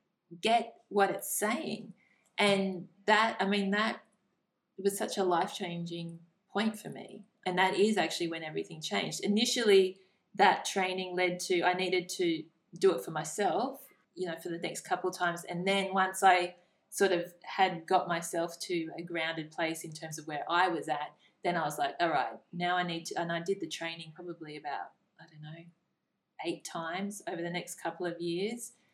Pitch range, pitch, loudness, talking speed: 170-195 Hz, 180 Hz, -32 LUFS, 190 wpm